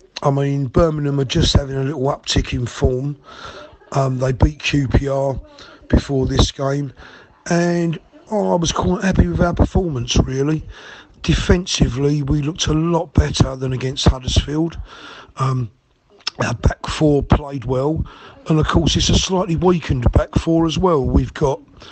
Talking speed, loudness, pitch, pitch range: 155 wpm, -18 LUFS, 140 Hz, 130-165 Hz